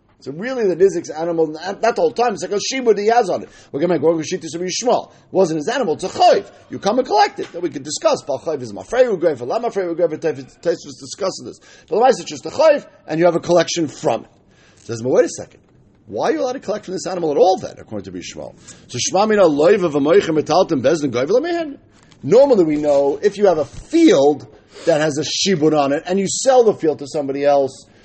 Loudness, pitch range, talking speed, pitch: -17 LUFS, 150-235 Hz, 245 wpm, 180 Hz